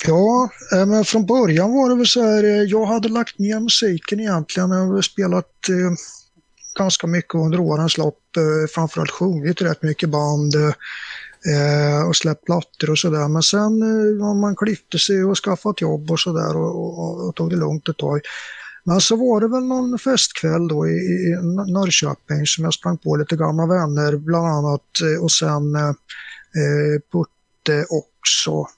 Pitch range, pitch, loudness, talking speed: 155-200 Hz, 170 Hz, -18 LUFS, 175 wpm